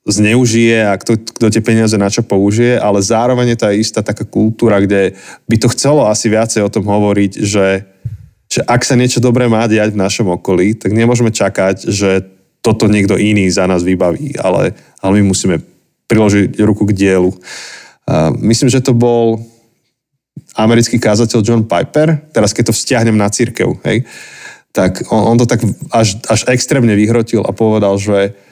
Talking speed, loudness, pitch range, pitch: 170 wpm, -12 LUFS, 100-120 Hz, 110 Hz